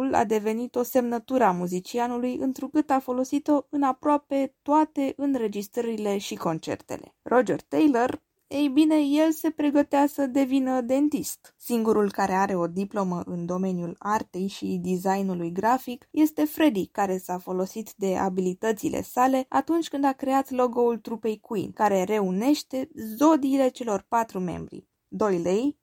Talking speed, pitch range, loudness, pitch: 135 wpm, 200-275 Hz, -25 LUFS, 245 Hz